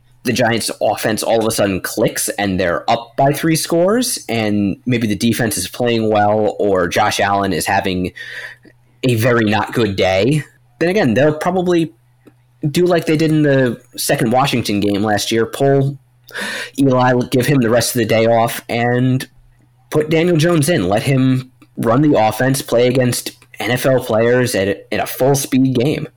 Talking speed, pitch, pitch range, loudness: 175 wpm, 125 Hz, 115-140 Hz, -15 LUFS